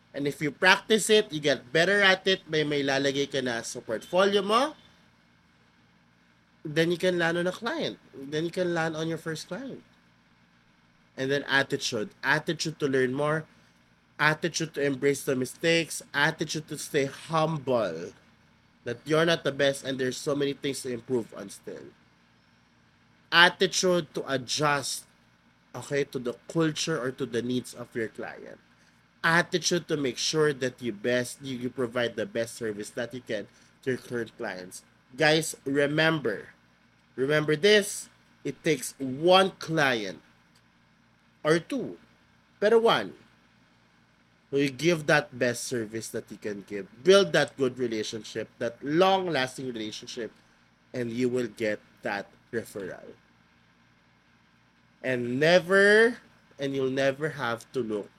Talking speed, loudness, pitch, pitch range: 145 wpm, -27 LUFS, 135 Hz, 110-160 Hz